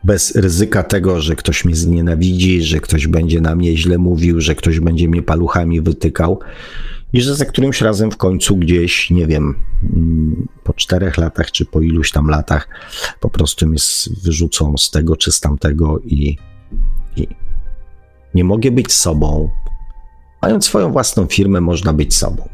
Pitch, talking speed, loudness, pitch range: 85 Hz, 160 wpm, -14 LUFS, 80-90 Hz